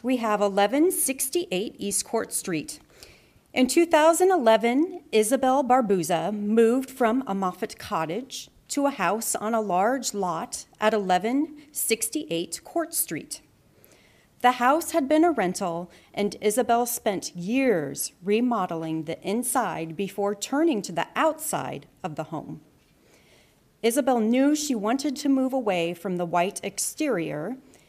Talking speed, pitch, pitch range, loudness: 125 wpm, 230 Hz, 200-270 Hz, -25 LUFS